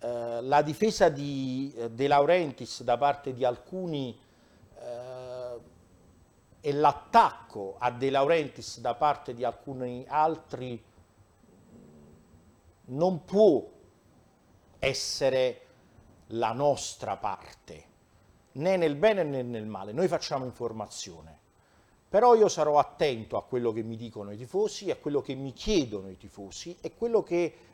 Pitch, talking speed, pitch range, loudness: 125 Hz, 125 wpm, 115-150 Hz, -28 LUFS